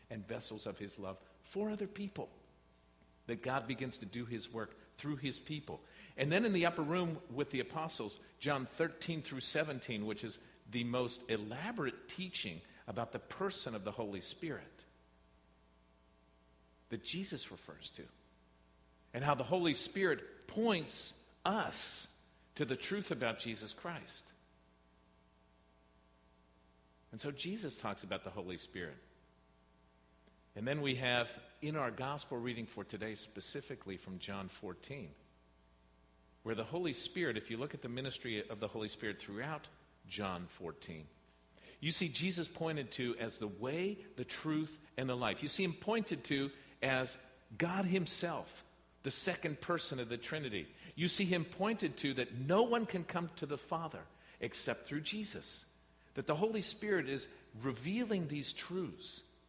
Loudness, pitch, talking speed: -40 LUFS, 125 Hz, 150 wpm